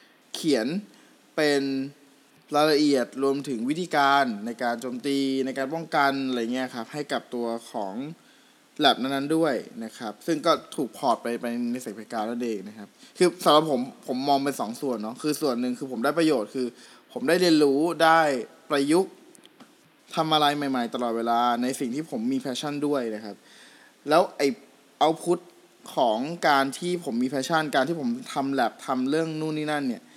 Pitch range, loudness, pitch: 125-165 Hz, -25 LUFS, 140 Hz